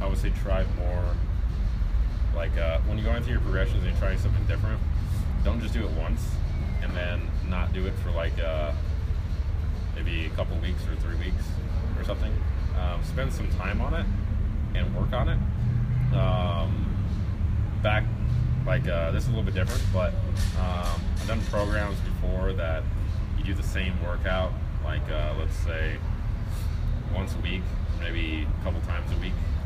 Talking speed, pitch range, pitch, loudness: 175 wpm, 80-95 Hz, 90 Hz, -28 LUFS